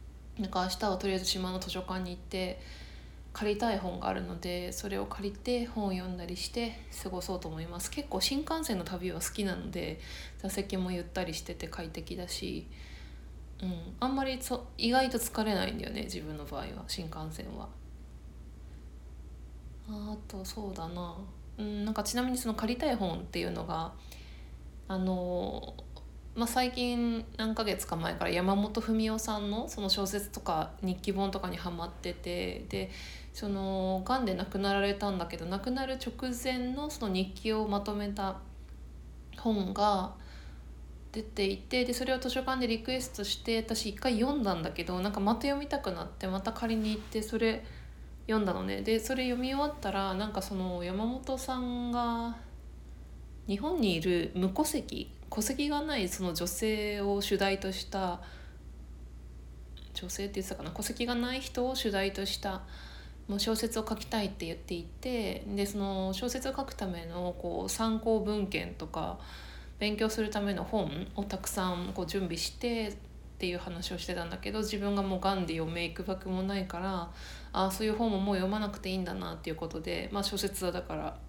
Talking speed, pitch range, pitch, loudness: 330 characters per minute, 170-220 Hz, 195 Hz, -34 LUFS